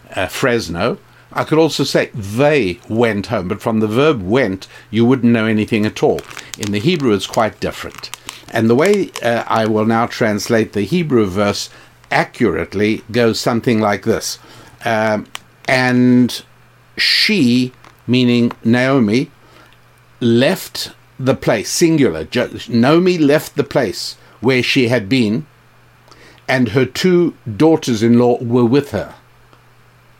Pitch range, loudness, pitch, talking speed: 110-130 Hz, -15 LUFS, 120 Hz, 130 wpm